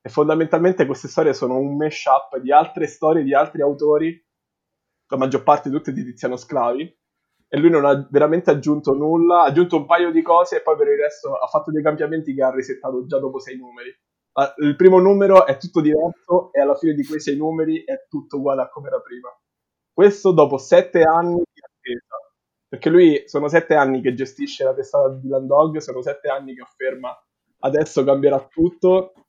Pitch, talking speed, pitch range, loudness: 155 Hz, 195 wpm, 140-175 Hz, -18 LUFS